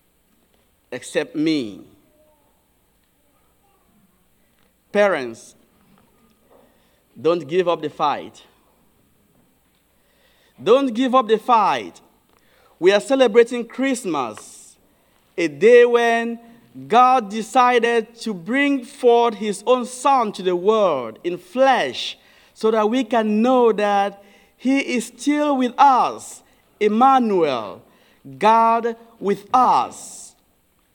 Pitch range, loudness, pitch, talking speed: 210-265 Hz, -18 LUFS, 235 Hz, 95 wpm